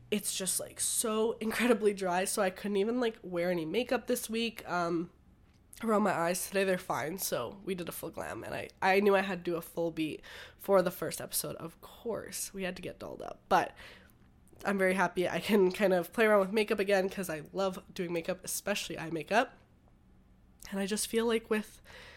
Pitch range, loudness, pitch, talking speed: 175-215 Hz, -32 LUFS, 195 Hz, 215 wpm